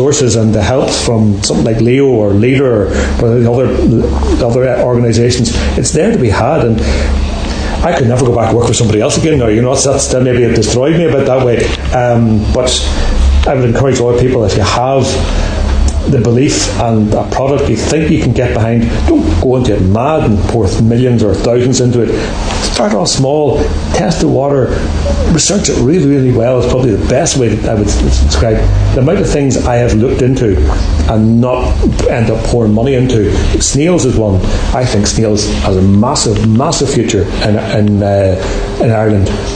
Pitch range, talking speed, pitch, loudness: 100-125 Hz, 190 wpm, 110 Hz, -10 LUFS